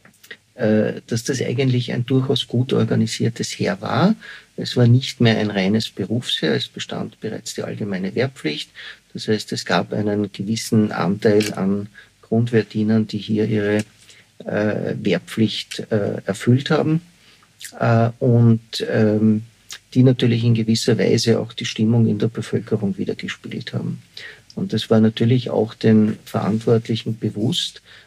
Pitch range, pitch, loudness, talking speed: 110-120 Hz, 110 Hz, -20 LUFS, 125 wpm